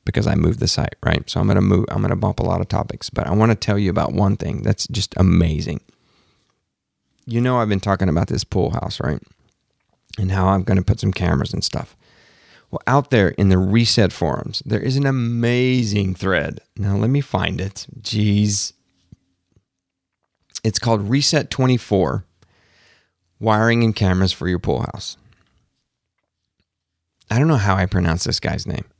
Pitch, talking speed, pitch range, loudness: 105 Hz, 175 wpm, 95-115 Hz, -19 LUFS